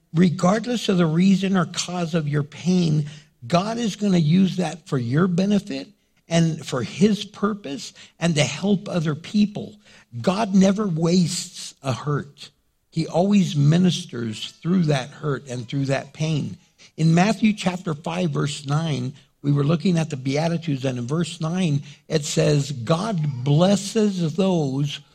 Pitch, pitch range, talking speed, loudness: 165 Hz, 145-185 Hz, 150 wpm, -22 LUFS